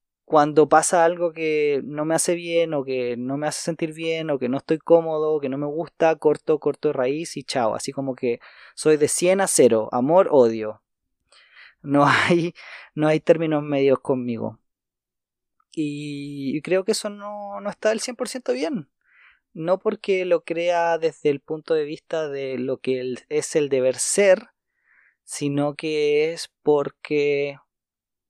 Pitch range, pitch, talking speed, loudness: 140-170 Hz, 150 Hz, 165 wpm, -22 LUFS